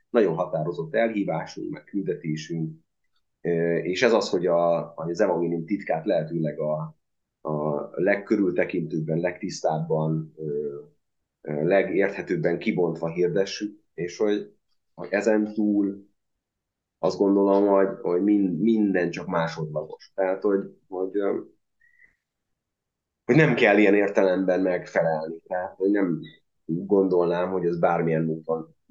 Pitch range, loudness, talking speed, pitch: 80-100 Hz, -25 LUFS, 105 wpm, 90 Hz